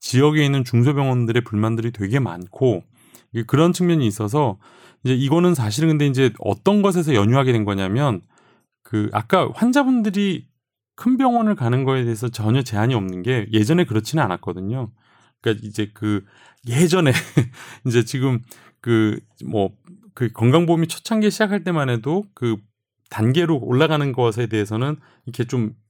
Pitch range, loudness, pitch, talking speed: 110-155 Hz, -20 LUFS, 125 Hz, 330 characters per minute